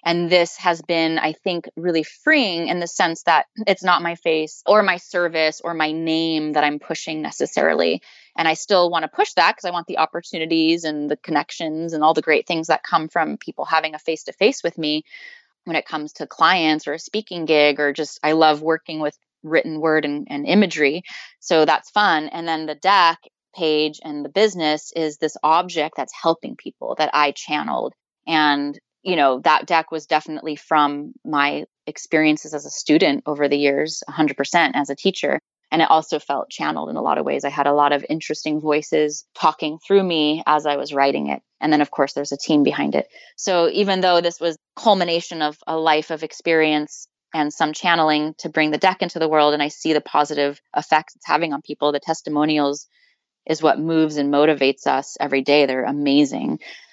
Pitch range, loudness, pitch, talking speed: 150-170 Hz, -20 LUFS, 155 Hz, 200 wpm